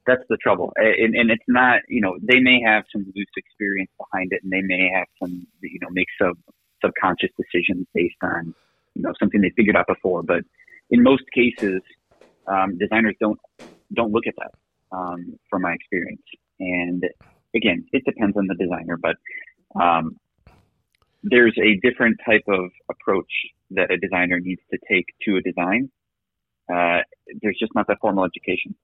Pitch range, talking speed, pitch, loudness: 90-120 Hz, 175 wpm, 100 Hz, -20 LUFS